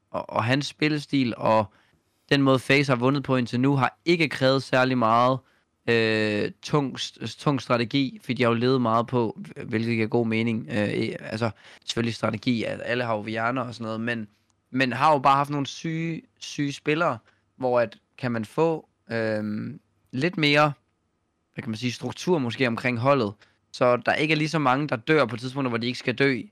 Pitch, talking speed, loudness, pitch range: 125 Hz, 195 wpm, -24 LUFS, 110-140 Hz